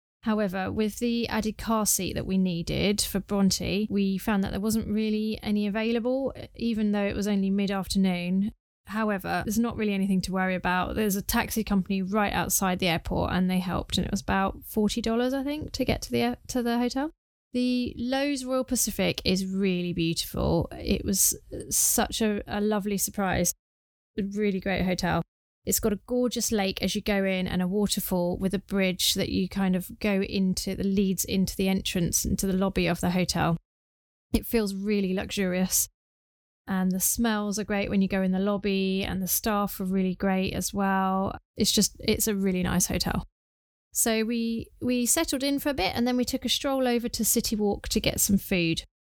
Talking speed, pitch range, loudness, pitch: 195 wpm, 185-220 Hz, -27 LUFS, 200 Hz